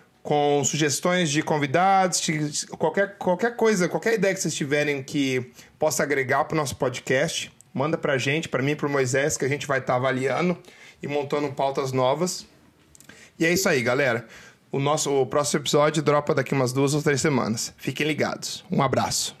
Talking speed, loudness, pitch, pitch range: 180 wpm, -24 LUFS, 150 Hz, 140-175 Hz